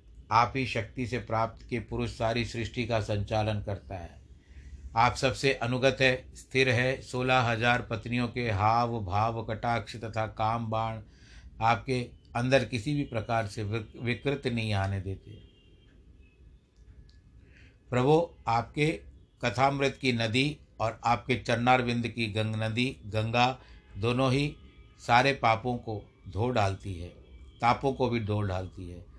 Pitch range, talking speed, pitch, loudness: 105-125 Hz, 135 wpm, 115 Hz, -29 LUFS